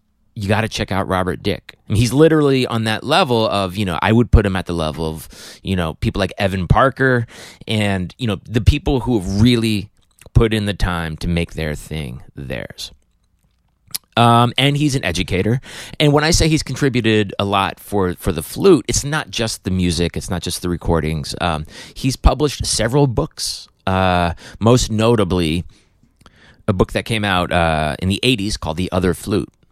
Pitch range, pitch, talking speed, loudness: 90-120 Hz, 105 Hz, 195 wpm, -18 LUFS